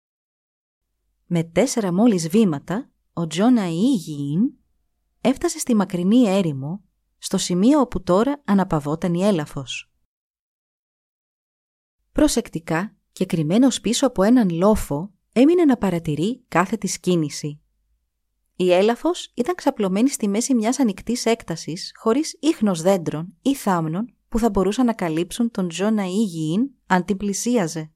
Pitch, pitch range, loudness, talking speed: 200 Hz, 175-240 Hz, -21 LUFS, 120 wpm